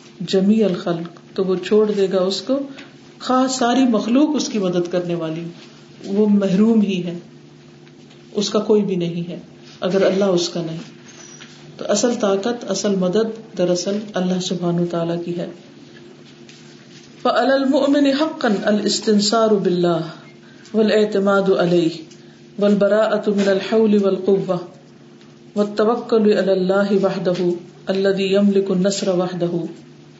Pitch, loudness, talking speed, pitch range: 195 Hz, -18 LUFS, 95 wpm, 180-215 Hz